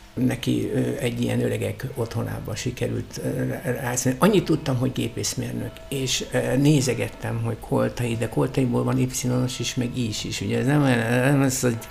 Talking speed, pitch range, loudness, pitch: 175 wpm, 120-130 Hz, -24 LUFS, 125 Hz